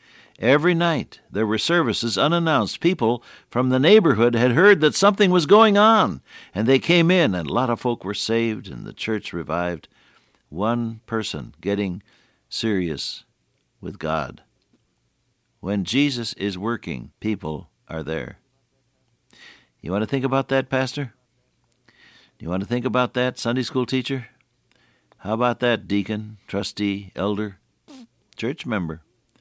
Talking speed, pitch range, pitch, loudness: 140 wpm, 100-135 Hz, 120 Hz, -21 LUFS